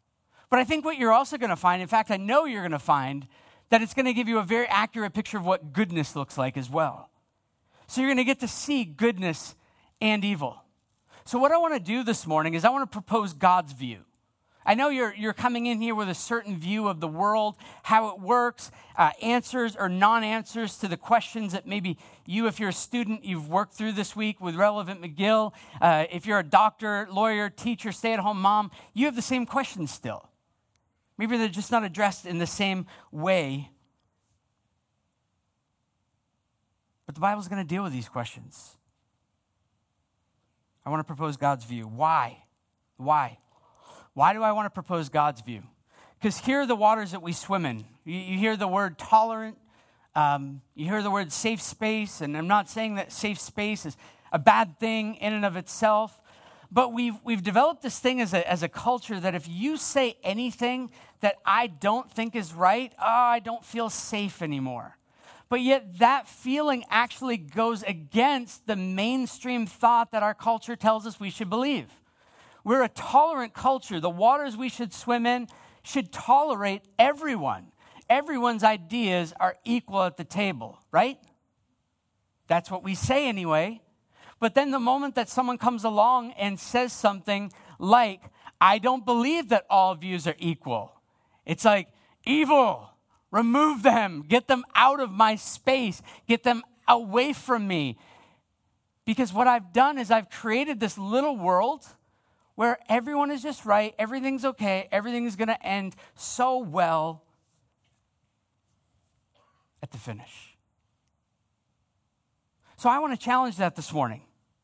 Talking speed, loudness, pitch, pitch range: 170 wpm, -25 LUFS, 210 Hz, 165-240 Hz